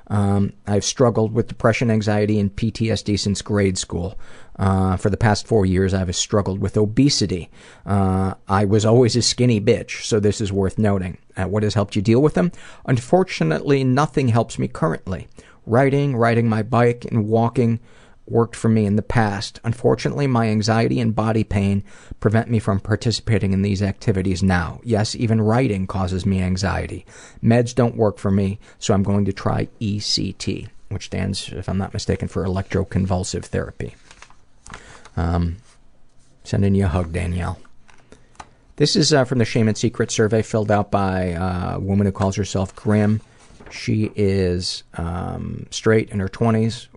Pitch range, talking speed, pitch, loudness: 95-115 Hz, 165 wpm, 105 Hz, -20 LUFS